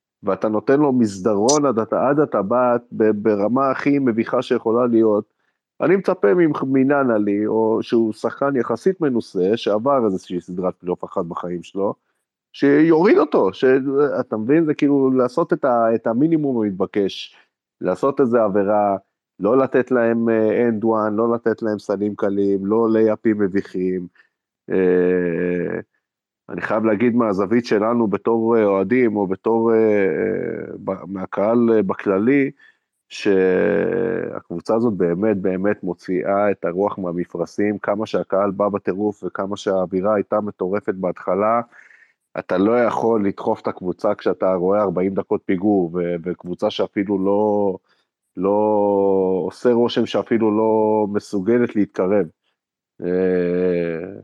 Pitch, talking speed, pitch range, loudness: 105 Hz, 115 wpm, 95-120 Hz, -19 LUFS